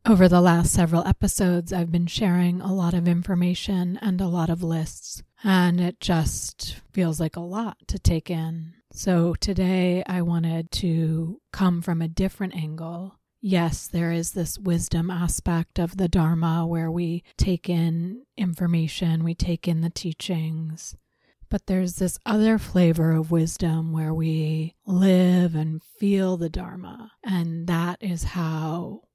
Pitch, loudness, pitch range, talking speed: 175 Hz, -24 LUFS, 165-185 Hz, 150 wpm